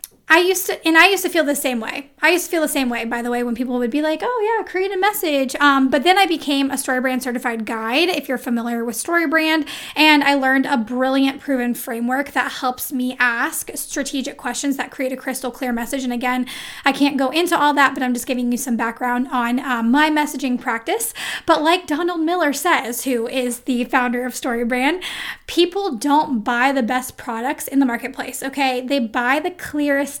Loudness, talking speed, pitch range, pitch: -19 LUFS, 215 wpm, 250-305 Hz, 270 Hz